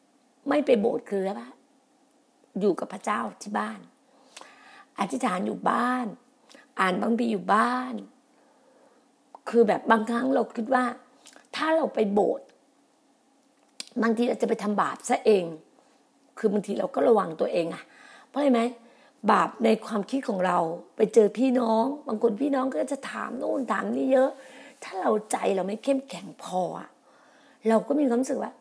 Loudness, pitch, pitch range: -26 LUFS, 250 Hz, 220-270 Hz